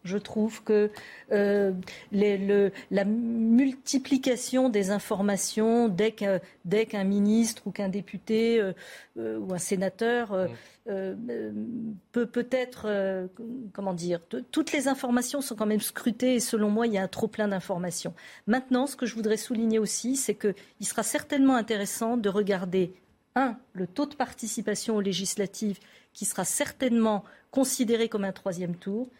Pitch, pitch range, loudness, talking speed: 215 Hz, 200-240 Hz, -28 LUFS, 155 wpm